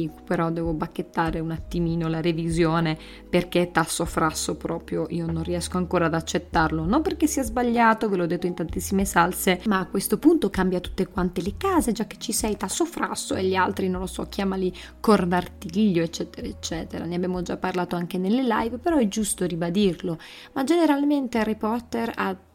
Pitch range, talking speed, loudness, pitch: 170-220 Hz, 180 wpm, -24 LUFS, 185 Hz